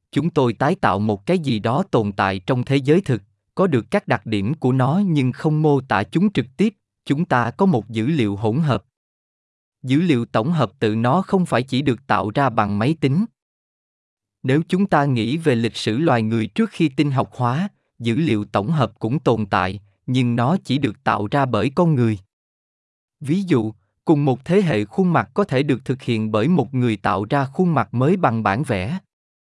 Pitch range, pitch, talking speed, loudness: 110-155 Hz, 130 Hz, 215 wpm, -20 LUFS